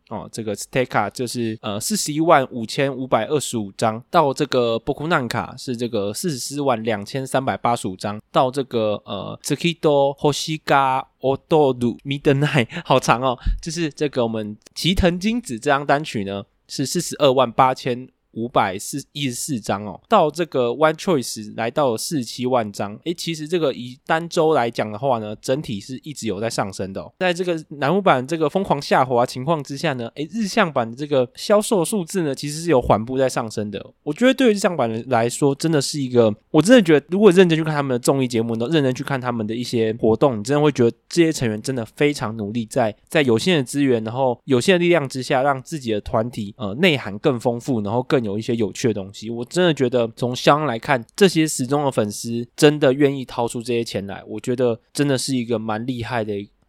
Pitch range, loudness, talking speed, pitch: 115-150 Hz, -20 LUFS, 335 characters per minute, 130 Hz